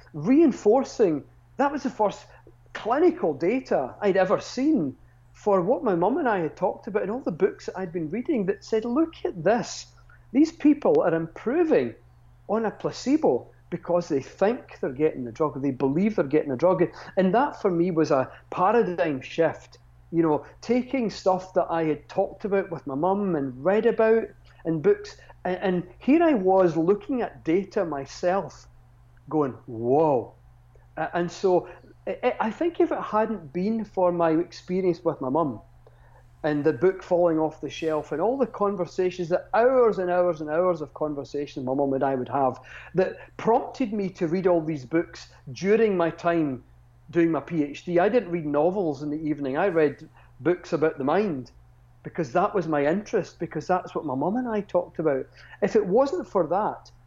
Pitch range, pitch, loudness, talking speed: 145-200 Hz, 175 Hz, -25 LUFS, 185 wpm